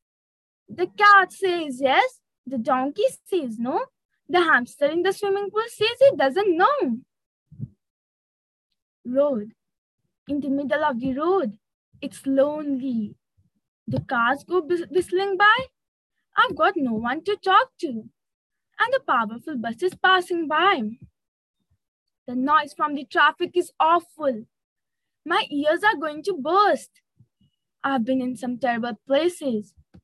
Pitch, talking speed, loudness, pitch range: 305 Hz, 130 wpm, -22 LUFS, 260-375 Hz